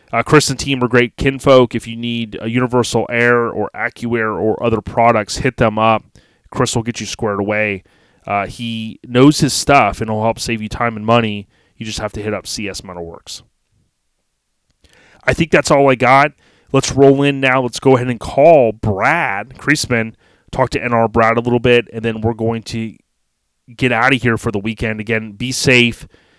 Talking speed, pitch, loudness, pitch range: 200 wpm, 115 Hz, -15 LUFS, 110-125 Hz